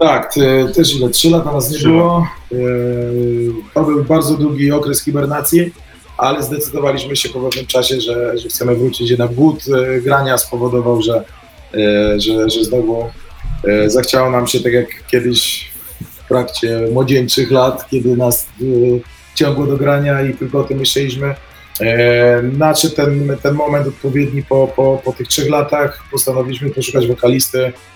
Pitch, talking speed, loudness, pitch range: 130 Hz, 150 wpm, -14 LUFS, 120-145 Hz